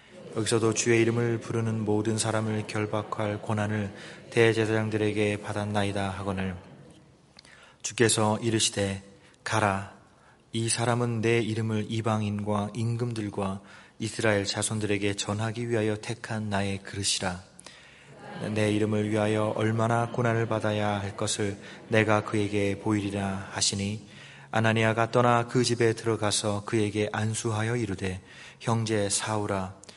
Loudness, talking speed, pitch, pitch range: -28 LUFS, 290 characters per minute, 110 Hz, 105-115 Hz